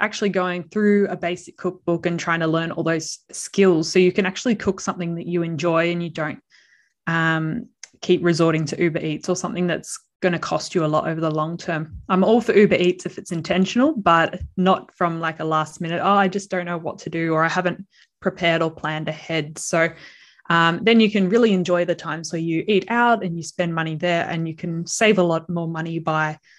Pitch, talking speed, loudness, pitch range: 175 Hz, 230 wpm, -21 LUFS, 165-185 Hz